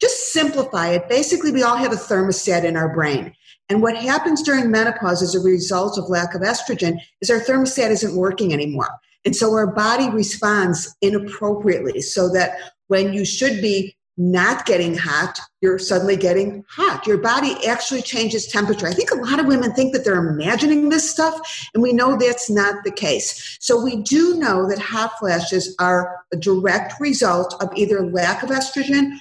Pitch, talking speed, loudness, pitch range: 210 Hz, 185 wpm, -19 LUFS, 185-250 Hz